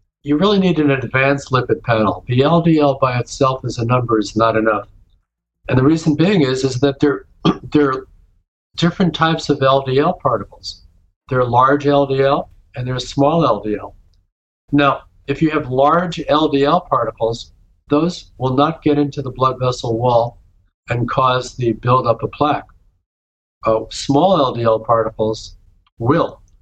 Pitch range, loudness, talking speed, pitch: 110-145 Hz, -16 LUFS, 150 wpm, 130 Hz